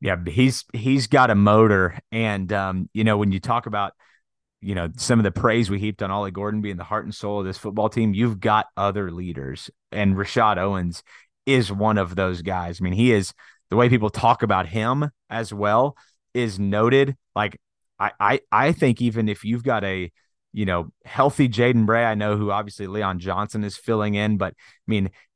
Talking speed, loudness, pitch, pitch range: 205 wpm, -22 LUFS, 105 Hz, 100-115 Hz